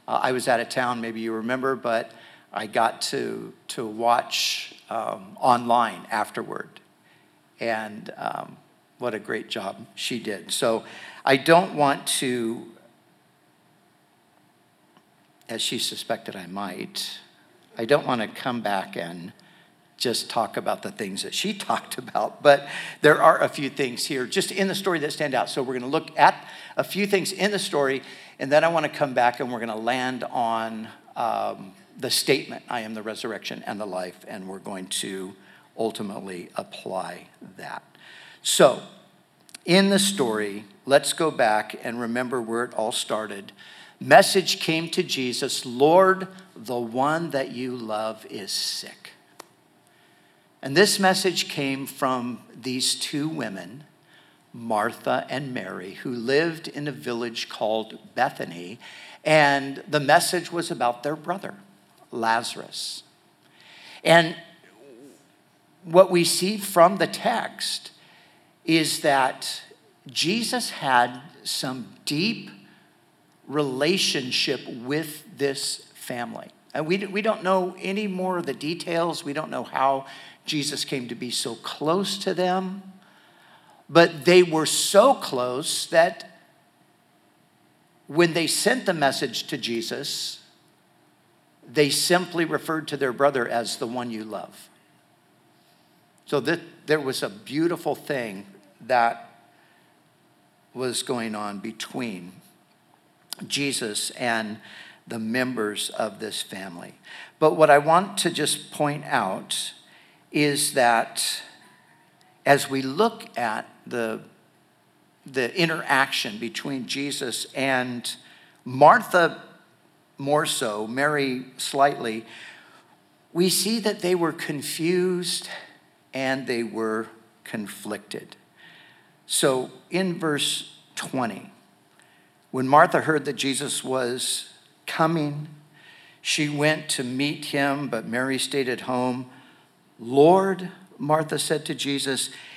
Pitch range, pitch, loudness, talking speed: 125-170 Hz, 140 Hz, -24 LUFS, 125 wpm